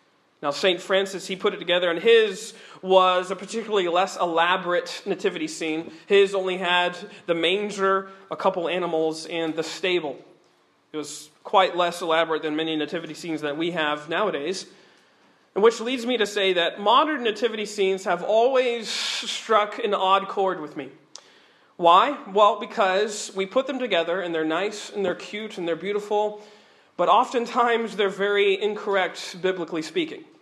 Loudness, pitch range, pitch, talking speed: -23 LUFS, 170-210 Hz, 190 Hz, 160 wpm